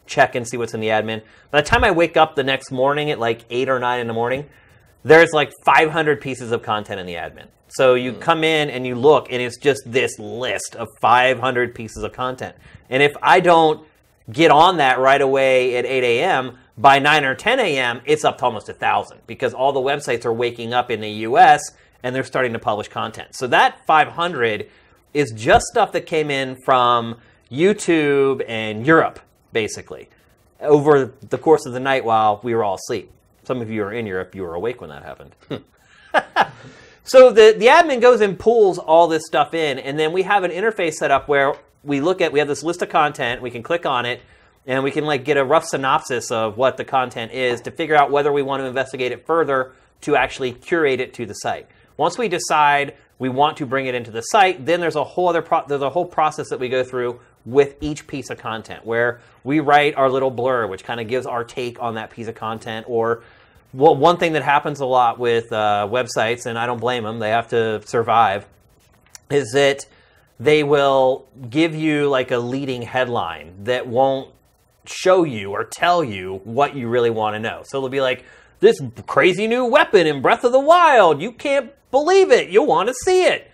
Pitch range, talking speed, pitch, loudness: 120-155 Hz, 215 wpm, 130 Hz, -18 LUFS